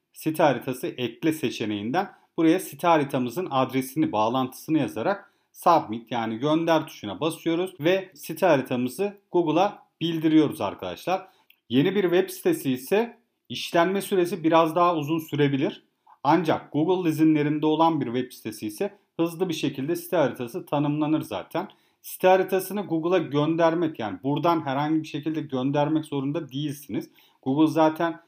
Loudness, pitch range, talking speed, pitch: -25 LUFS, 140-175 Hz, 130 wpm, 160 Hz